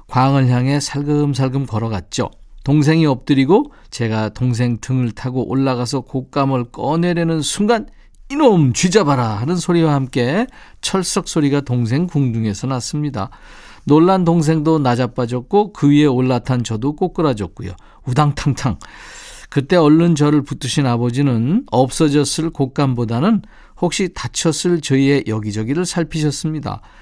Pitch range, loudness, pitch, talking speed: 125-160 Hz, -17 LUFS, 140 Hz, 305 characters per minute